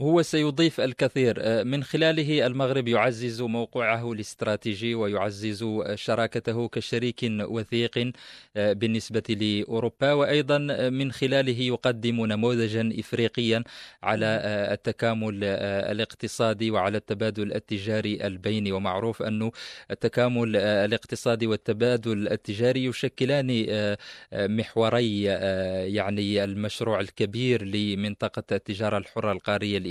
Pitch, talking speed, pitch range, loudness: 115 Hz, 85 wpm, 105-120 Hz, -26 LUFS